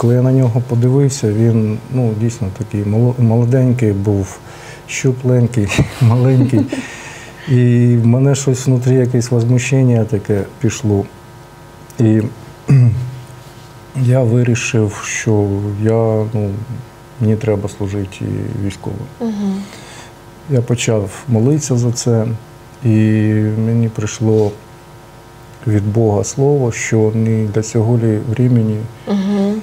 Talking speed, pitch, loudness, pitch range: 95 wpm, 120 Hz, -15 LUFS, 110-125 Hz